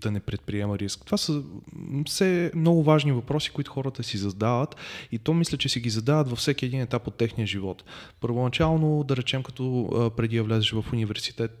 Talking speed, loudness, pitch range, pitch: 190 wpm, -26 LUFS, 110-150 Hz, 125 Hz